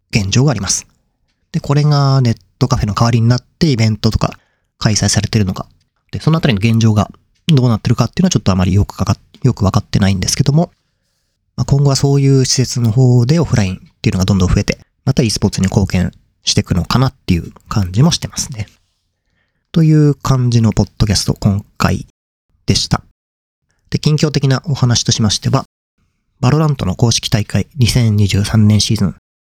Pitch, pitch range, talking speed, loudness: 115 Hz, 100-135 Hz, 395 characters per minute, -14 LUFS